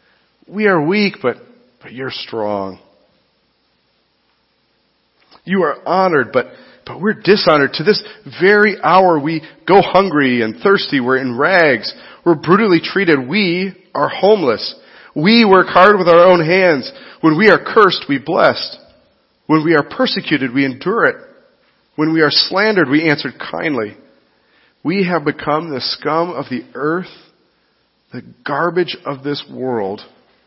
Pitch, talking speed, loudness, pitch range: 165 Hz, 140 wpm, -14 LUFS, 145-195 Hz